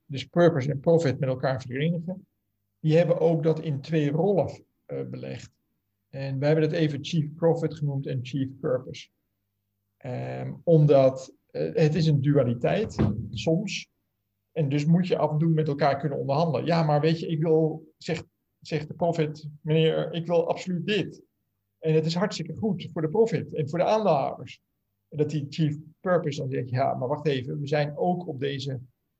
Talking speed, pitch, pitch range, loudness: 185 wpm, 150 Hz, 135-165 Hz, -26 LUFS